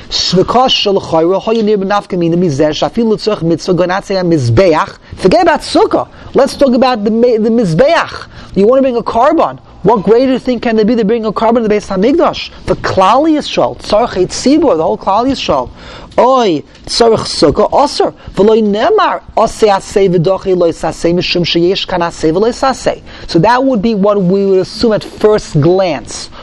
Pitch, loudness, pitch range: 210 Hz, -11 LUFS, 180-235 Hz